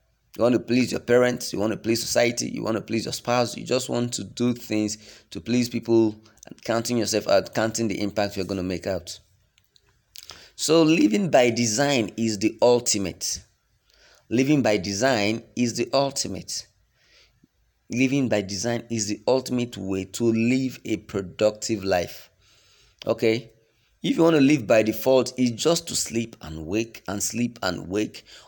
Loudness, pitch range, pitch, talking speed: -24 LUFS, 105-120 Hz, 115 Hz, 170 wpm